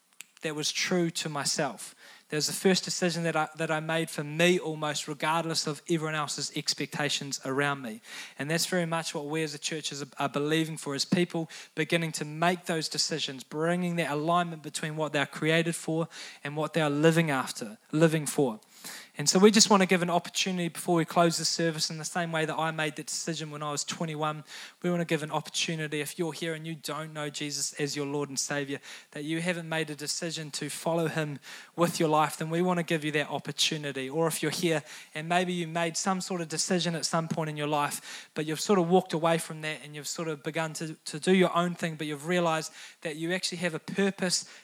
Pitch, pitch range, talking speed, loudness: 160 Hz, 150-170 Hz, 235 wpm, -29 LUFS